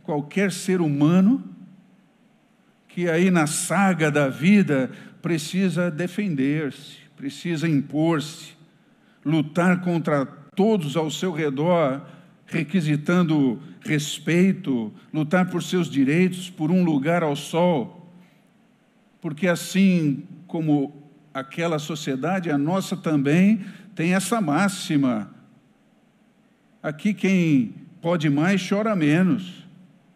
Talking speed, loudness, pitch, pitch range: 95 wpm, -22 LUFS, 175 Hz, 150-190 Hz